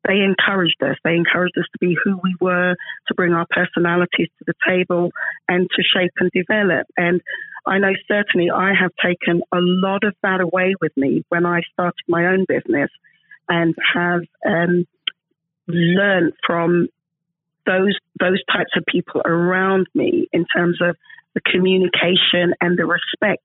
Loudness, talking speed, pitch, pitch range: -18 LUFS, 160 wpm, 180 Hz, 170-190 Hz